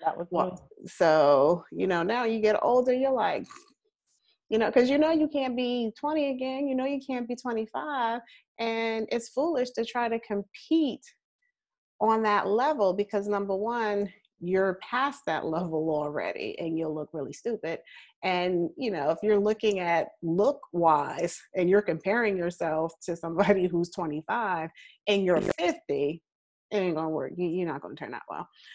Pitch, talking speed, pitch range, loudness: 205 Hz, 165 wpm, 175-245 Hz, -28 LUFS